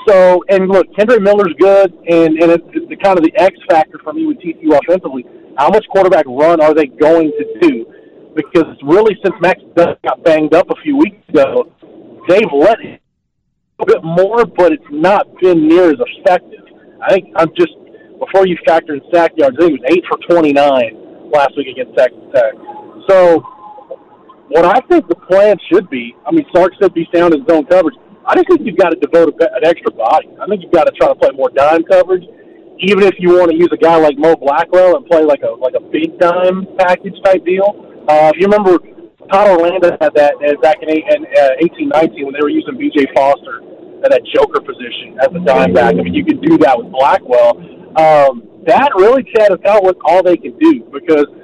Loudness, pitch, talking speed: -11 LUFS, 185 Hz, 210 wpm